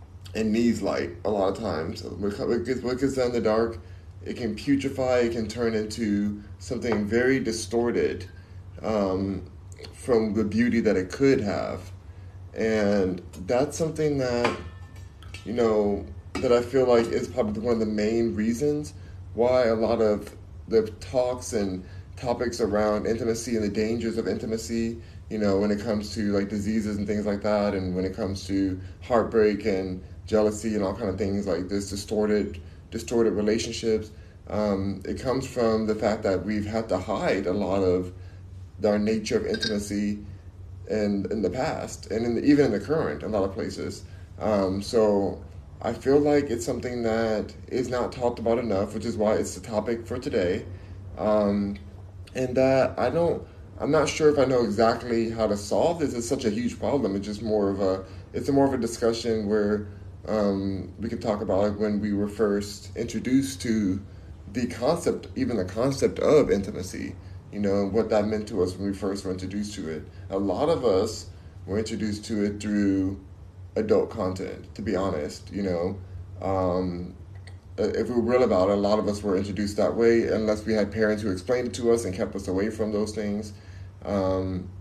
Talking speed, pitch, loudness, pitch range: 185 wpm, 105 Hz, -26 LUFS, 95-115 Hz